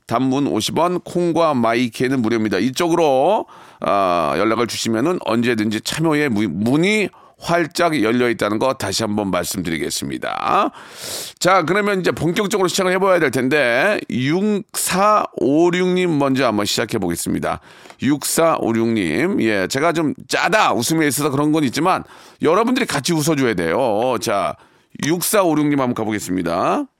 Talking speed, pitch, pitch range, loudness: 310 characters per minute, 150 Hz, 115-175 Hz, -18 LUFS